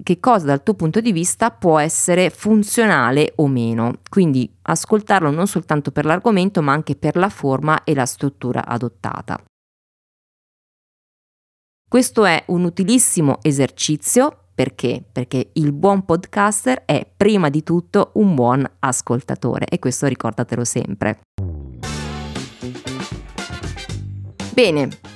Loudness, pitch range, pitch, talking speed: -18 LUFS, 125-195 Hz, 155 Hz, 115 wpm